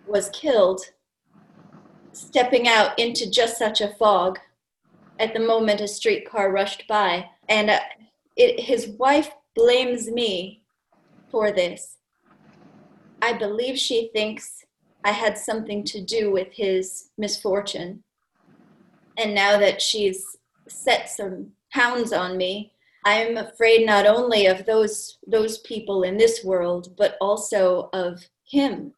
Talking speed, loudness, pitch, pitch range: 130 wpm, -21 LUFS, 210 Hz, 195-230 Hz